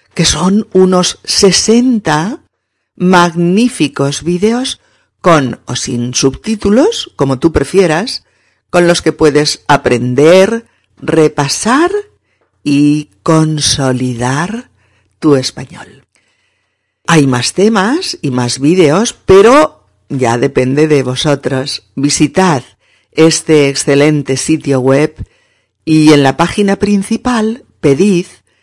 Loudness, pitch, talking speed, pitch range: -10 LUFS, 155 Hz, 95 wpm, 135-195 Hz